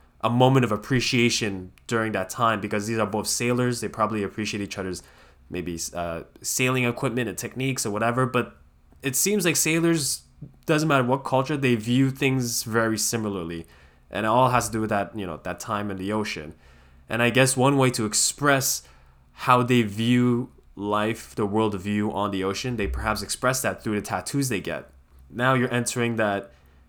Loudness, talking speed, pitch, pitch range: -24 LUFS, 185 wpm, 110 Hz, 95-125 Hz